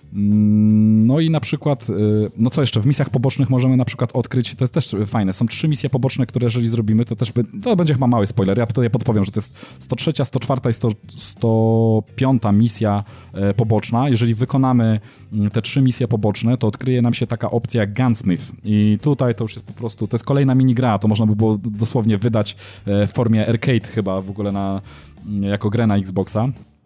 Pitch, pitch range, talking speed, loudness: 115 Hz, 105-125 Hz, 195 wpm, -18 LUFS